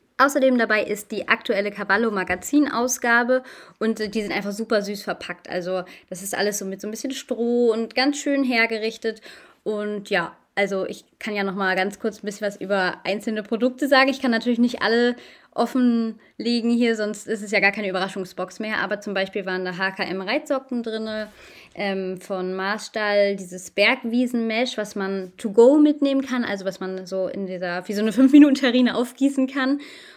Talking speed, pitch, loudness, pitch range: 180 wpm, 215 Hz, -22 LUFS, 195-245 Hz